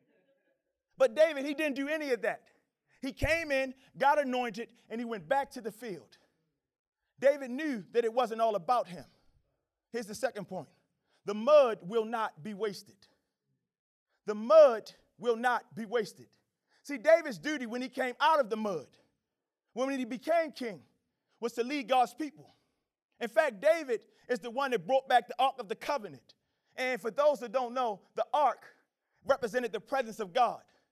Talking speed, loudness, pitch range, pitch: 175 wpm, -31 LUFS, 230-280 Hz, 250 Hz